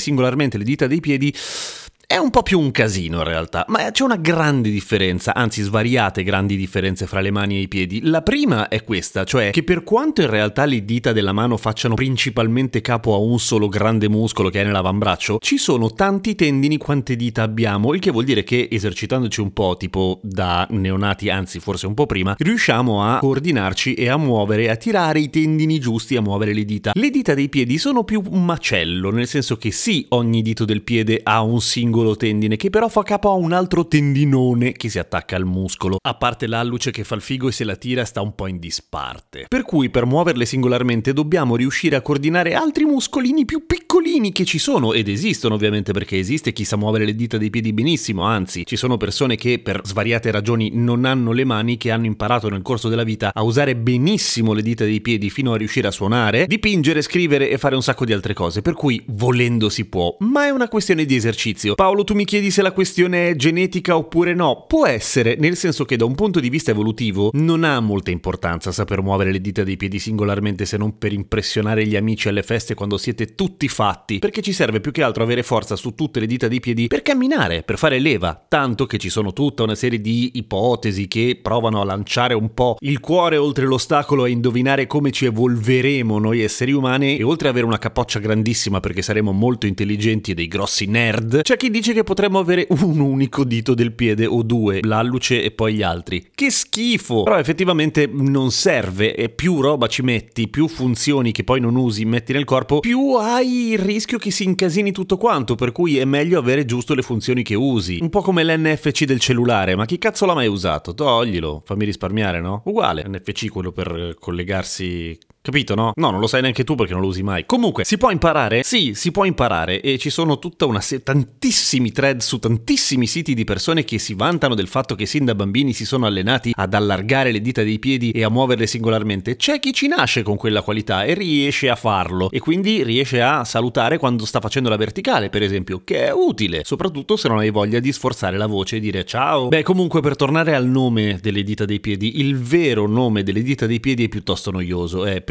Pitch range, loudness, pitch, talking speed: 105-145 Hz, -18 LUFS, 120 Hz, 215 wpm